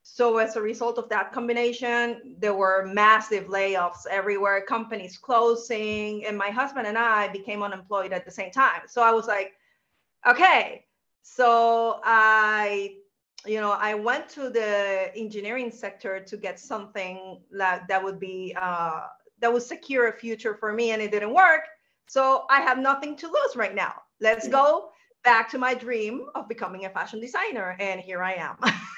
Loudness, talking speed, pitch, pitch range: -24 LUFS, 170 wpm, 220 Hz, 200-240 Hz